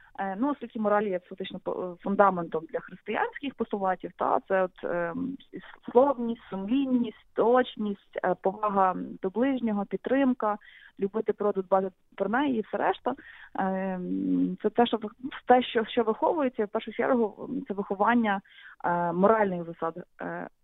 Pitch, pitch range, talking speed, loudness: 210 Hz, 190-240 Hz, 135 wpm, -28 LUFS